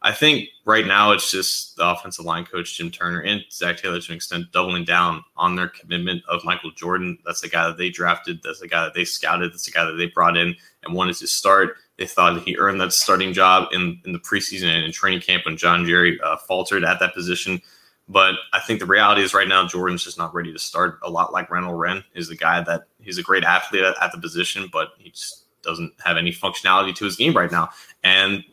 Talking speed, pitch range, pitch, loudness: 245 wpm, 85-95 Hz, 90 Hz, -19 LUFS